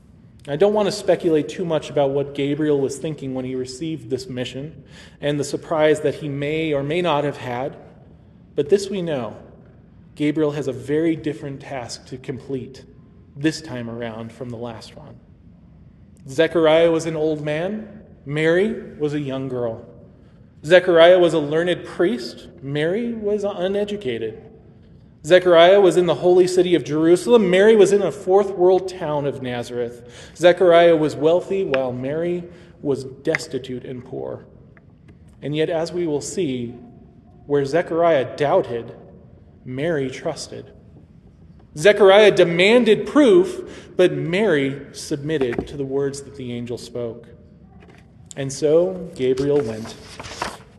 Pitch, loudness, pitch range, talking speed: 150 Hz, -19 LUFS, 130-175 Hz, 140 wpm